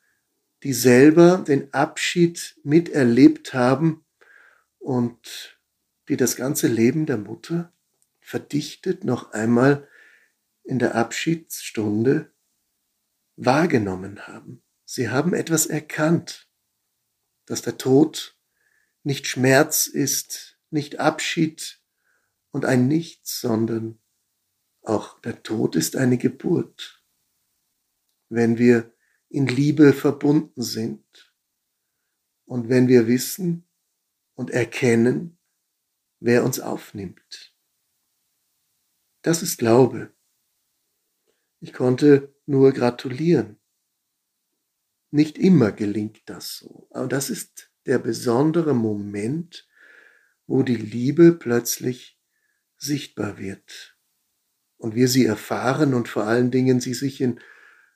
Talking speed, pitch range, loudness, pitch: 95 wpm, 120-160 Hz, -21 LUFS, 135 Hz